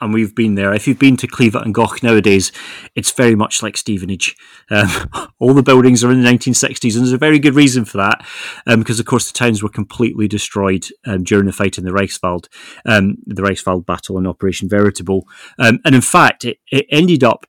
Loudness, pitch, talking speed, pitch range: -14 LUFS, 110 Hz, 220 wpm, 100-125 Hz